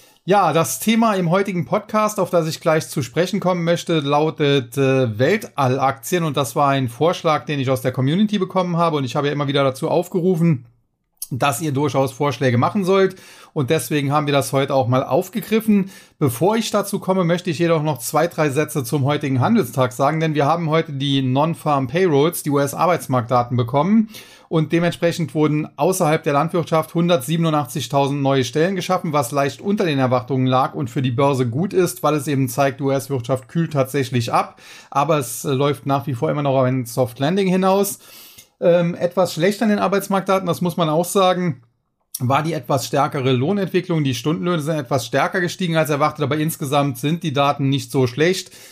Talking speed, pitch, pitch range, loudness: 185 wpm, 150 Hz, 140-175 Hz, -19 LUFS